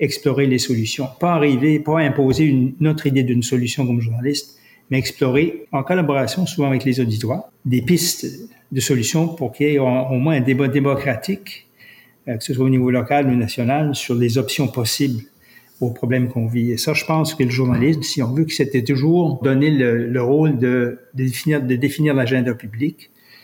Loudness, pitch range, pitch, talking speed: -18 LUFS, 125-150 Hz, 135 Hz, 195 wpm